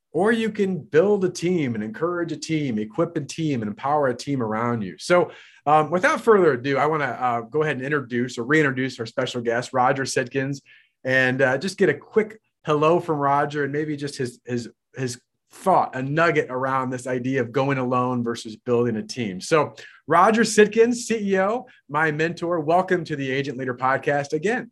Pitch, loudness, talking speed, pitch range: 140 Hz, -22 LUFS, 195 wpm, 125-170 Hz